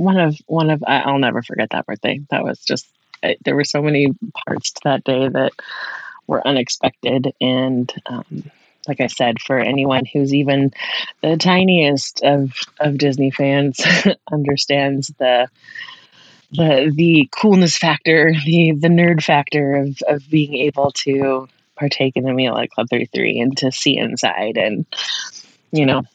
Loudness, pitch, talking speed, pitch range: -17 LUFS, 140 Hz, 155 wpm, 135-155 Hz